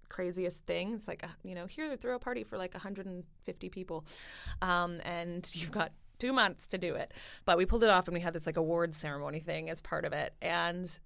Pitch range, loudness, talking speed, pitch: 165-190 Hz, -35 LUFS, 220 wpm, 175 Hz